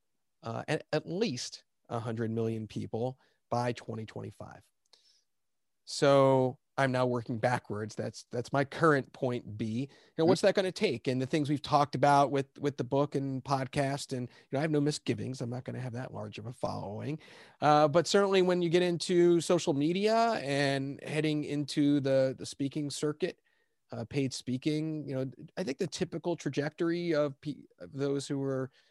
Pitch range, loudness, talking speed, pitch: 125-155 Hz, -31 LUFS, 185 wpm, 140 Hz